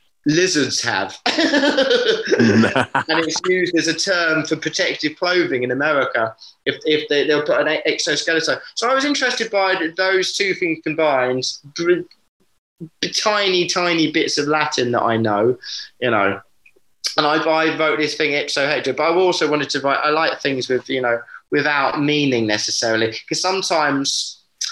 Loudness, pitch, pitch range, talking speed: -18 LUFS, 160 Hz, 145-195 Hz, 160 wpm